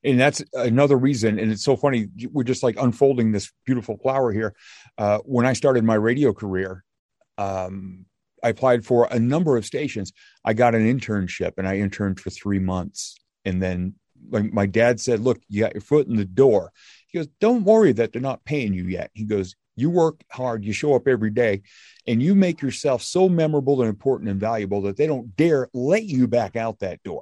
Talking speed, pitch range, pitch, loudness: 210 wpm, 100-135 Hz, 115 Hz, -22 LUFS